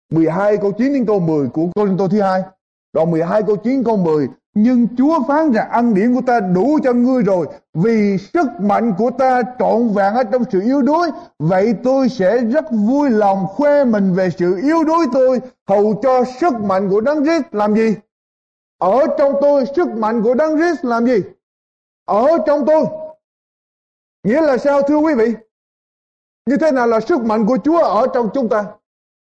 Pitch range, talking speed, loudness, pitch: 205-285 Hz, 195 wpm, -15 LUFS, 235 Hz